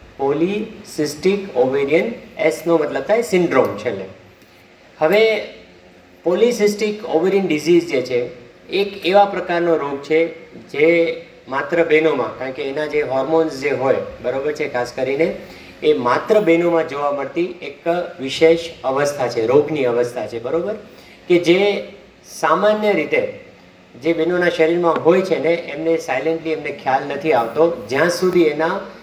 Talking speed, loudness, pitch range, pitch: 130 wpm, -18 LUFS, 145-180 Hz, 165 Hz